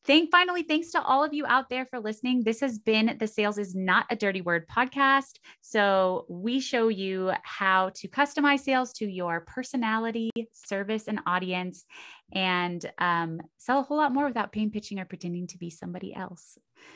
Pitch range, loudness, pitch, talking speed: 185-260 Hz, -27 LUFS, 220 Hz, 185 wpm